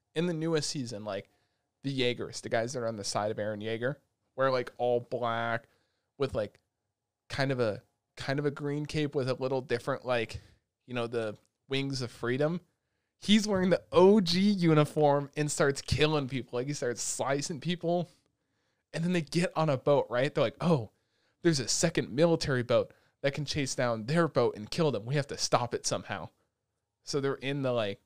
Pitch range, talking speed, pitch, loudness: 115-150 Hz, 195 wpm, 135 Hz, -30 LUFS